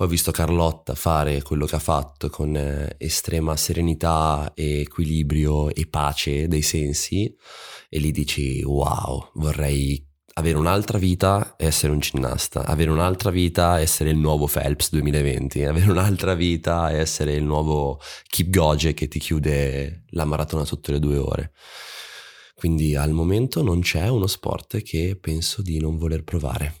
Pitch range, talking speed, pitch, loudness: 75-85 Hz, 155 wpm, 80 Hz, -22 LUFS